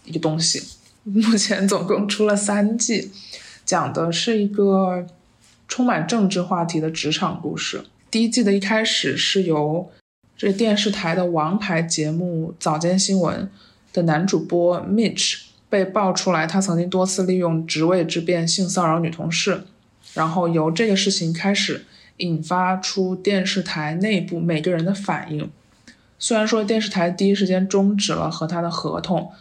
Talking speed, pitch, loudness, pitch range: 245 characters per minute, 185 Hz, -20 LUFS, 165-200 Hz